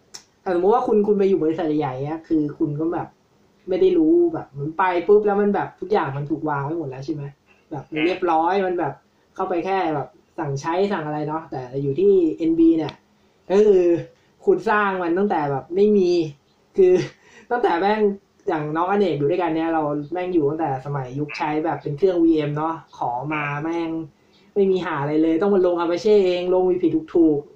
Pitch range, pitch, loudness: 155-200 Hz, 170 Hz, -21 LUFS